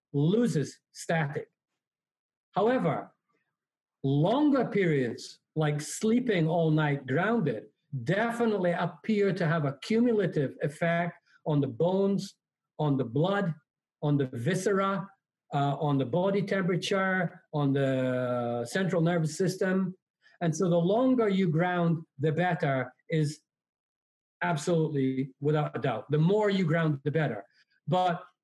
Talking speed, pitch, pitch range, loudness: 120 wpm, 170 Hz, 150-190 Hz, -28 LUFS